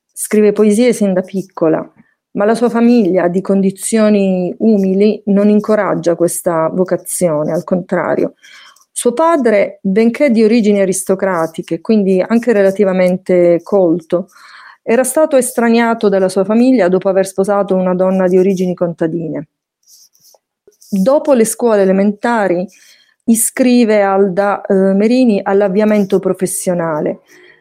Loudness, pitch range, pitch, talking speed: -13 LUFS, 185-225 Hz, 200 Hz, 115 wpm